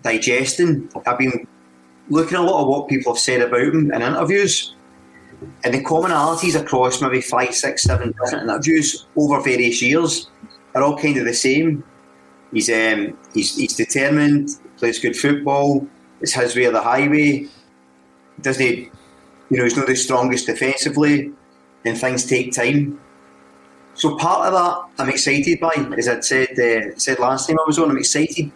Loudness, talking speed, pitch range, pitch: -18 LUFS, 165 wpm, 115-150 Hz, 130 Hz